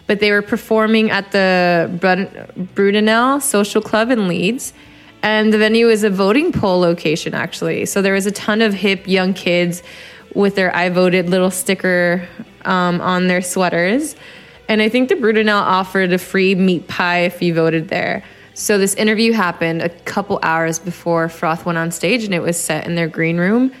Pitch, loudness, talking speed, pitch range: 190 Hz, -16 LUFS, 185 wpm, 175-215 Hz